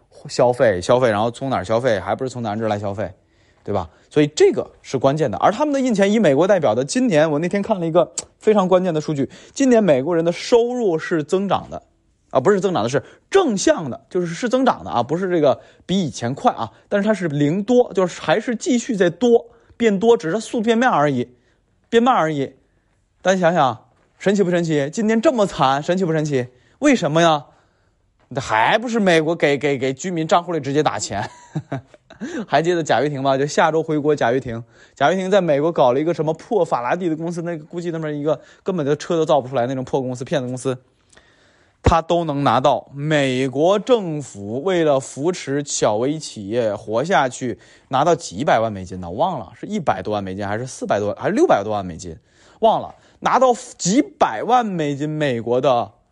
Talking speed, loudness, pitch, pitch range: 305 characters per minute, -19 LUFS, 155 Hz, 130-195 Hz